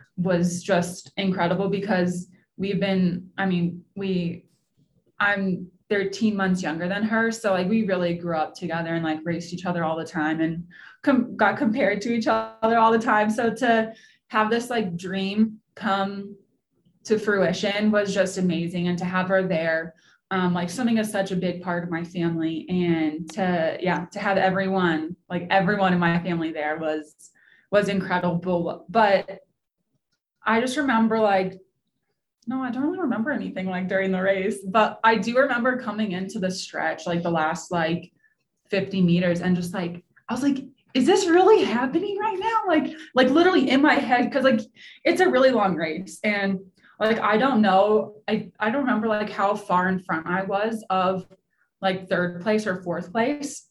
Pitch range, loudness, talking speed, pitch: 175-220 Hz, -23 LUFS, 180 wpm, 195 Hz